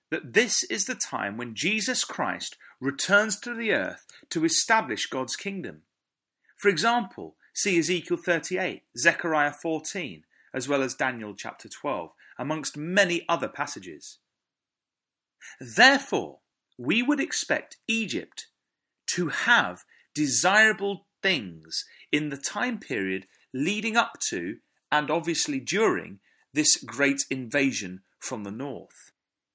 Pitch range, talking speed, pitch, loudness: 140-225 Hz, 120 wpm, 175 Hz, -26 LUFS